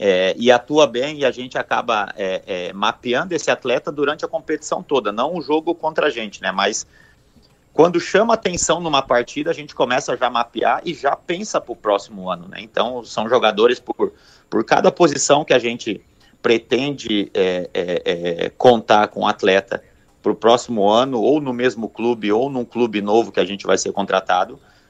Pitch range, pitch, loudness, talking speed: 115-170 Hz, 145 Hz, -19 LUFS, 195 wpm